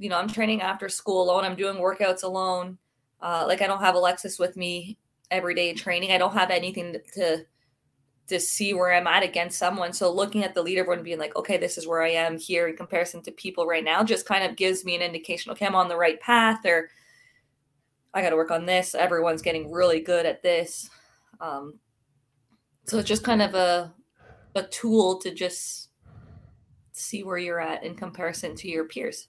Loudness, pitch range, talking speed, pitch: -25 LUFS, 165-190 Hz, 210 wpm, 175 Hz